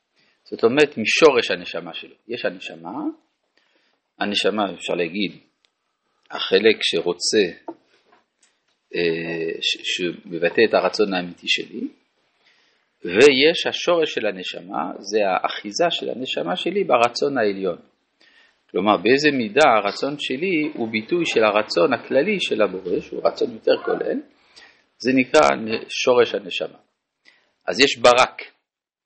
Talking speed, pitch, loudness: 110 wpm, 335 Hz, -20 LUFS